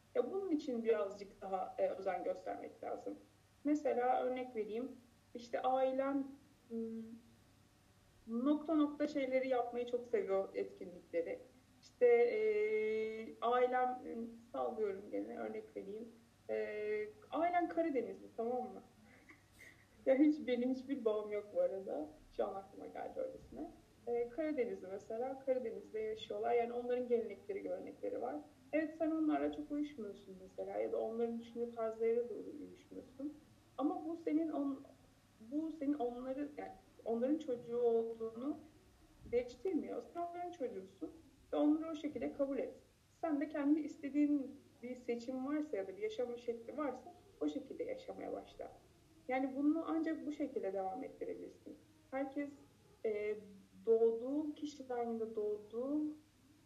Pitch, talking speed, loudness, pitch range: 255 Hz, 125 wpm, -40 LUFS, 230-300 Hz